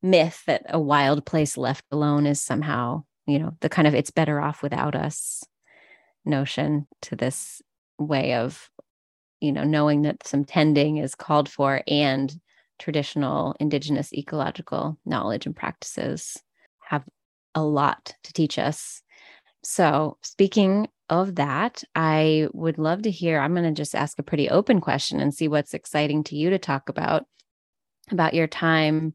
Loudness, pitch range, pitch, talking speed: -24 LUFS, 145-160 Hz, 150 Hz, 155 wpm